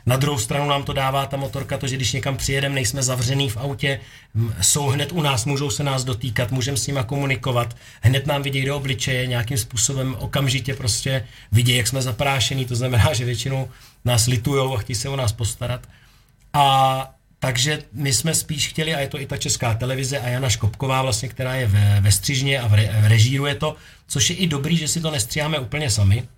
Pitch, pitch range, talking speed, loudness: 130 Hz, 120-140 Hz, 210 wpm, -21 LUFS